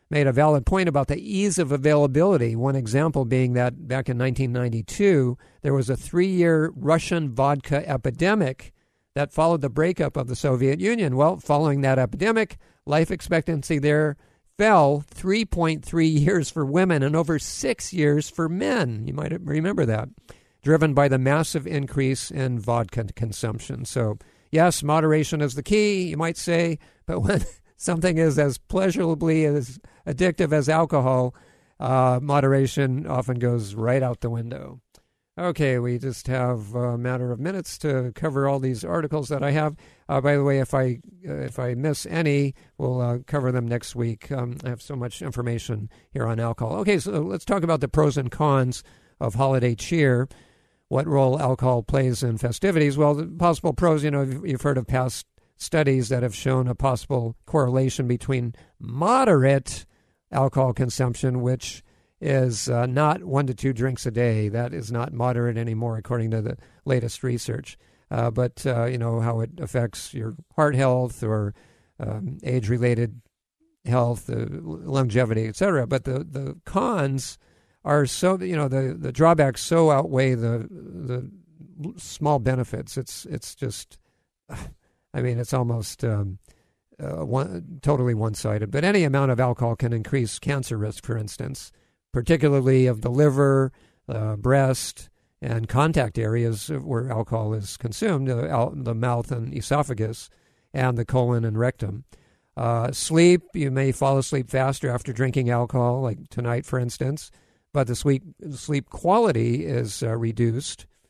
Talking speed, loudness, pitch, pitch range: 160 wpm, -23 LUFS, 130 Hz, 120-150 Hz